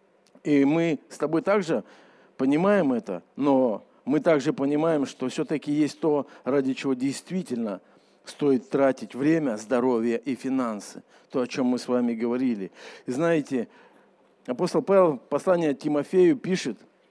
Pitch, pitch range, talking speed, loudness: 145 Hz, 130-165 Hz, 135 wpm, -25 LUFS